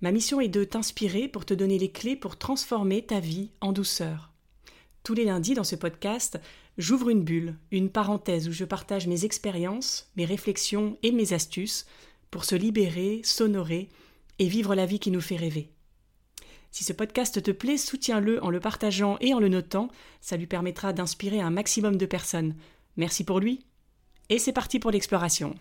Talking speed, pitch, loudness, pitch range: 185 wpm, 200 Hz, -28 LUFS, 180-220 Hz